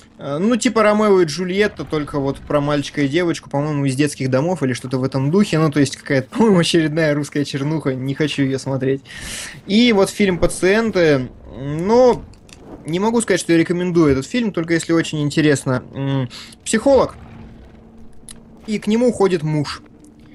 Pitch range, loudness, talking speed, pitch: 140-190 Hz, -18 LUFS, 160 wpm, 155 Hz